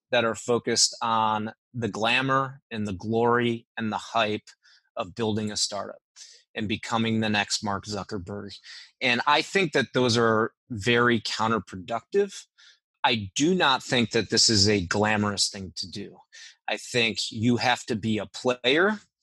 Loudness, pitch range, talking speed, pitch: -25 LUFS, 105-120 Hz, 155 wpm, 115 Hz